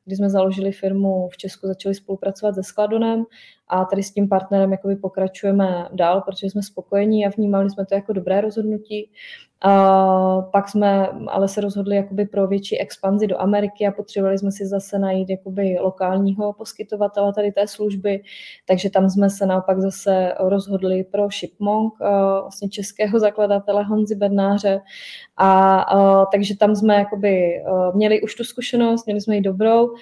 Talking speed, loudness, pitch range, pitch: 160 wpm, -19 LUFS, 195-205 Hz, 200 Hz